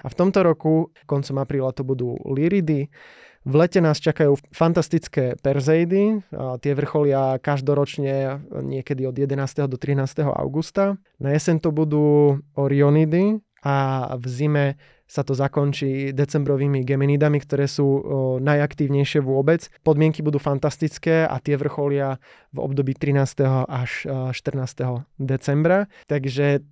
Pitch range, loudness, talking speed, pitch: 135-155 Hz, -21 LUFS, 120 wpm, 145 Hz